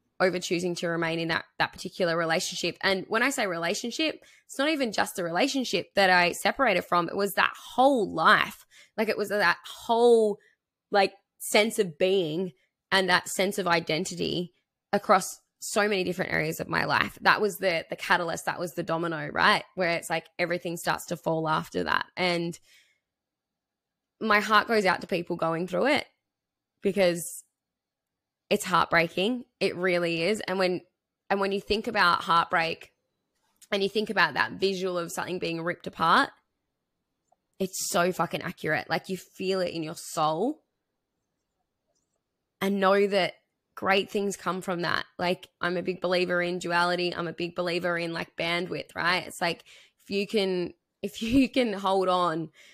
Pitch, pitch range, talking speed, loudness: 180 Hz, 170-200 Hz, 170 wpm, -26 LUFS